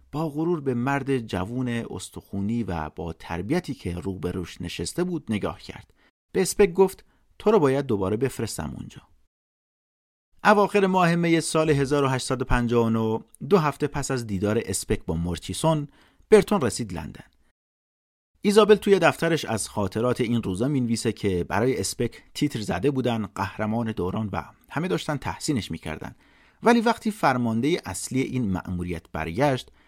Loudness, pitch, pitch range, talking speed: -25 LUFS, 120 Hz, 95-155 Hz, 140 wpm